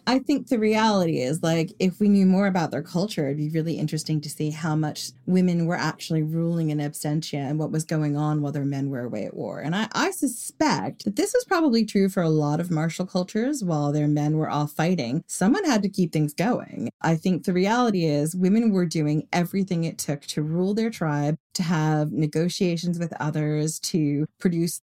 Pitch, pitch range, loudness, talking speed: 165 Hz, 150-190 Hz, -24 LUFS, 210 wpm